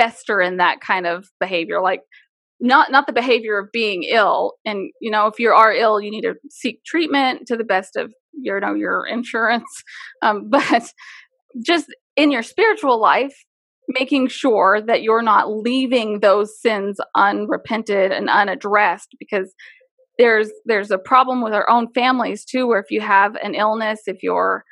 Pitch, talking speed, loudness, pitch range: 225 Hz, 170 wpm, -18 LUFS, 205-255 Hz